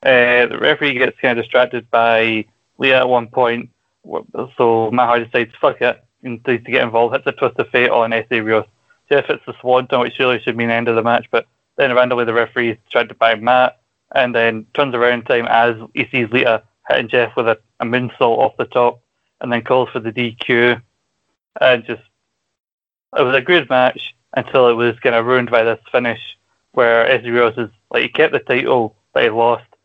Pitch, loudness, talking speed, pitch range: 120 Hz, -16 LUFS, 215 wpm, 115-125 Hz